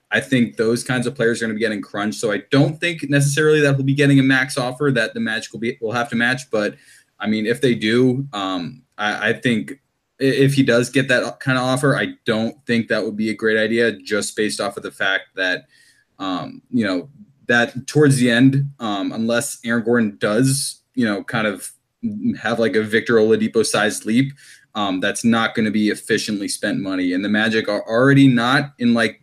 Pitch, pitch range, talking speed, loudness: 125 Hz, 115-140 Hz, 220 wpm, -19 LUFS